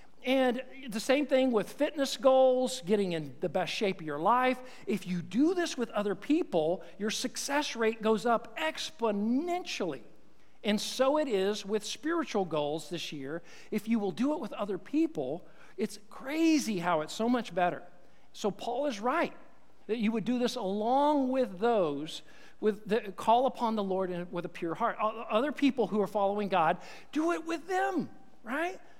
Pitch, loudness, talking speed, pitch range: 225 Hz, -31 LUFS, 175 wpm, 200-265 Hz